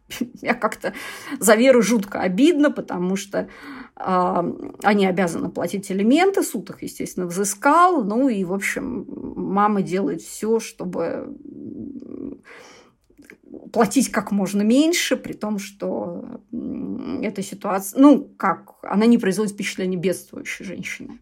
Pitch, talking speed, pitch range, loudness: 230 Hz, 120 wpm, 195-275 Hz, -21 LUFS